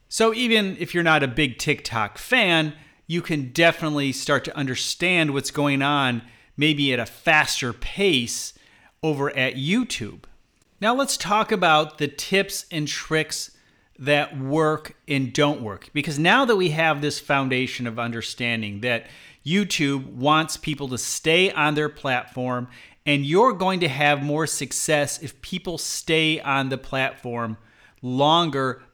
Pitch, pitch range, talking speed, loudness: 145 Hz, 130-160 Hz, 145 wpm, -22 LUFS